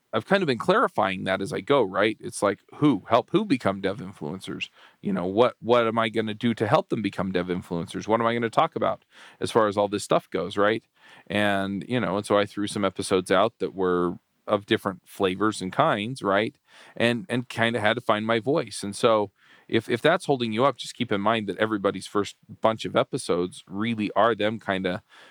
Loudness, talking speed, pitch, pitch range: -25 LUFS, 230 wpm, 105 Hz, 95-115 Hz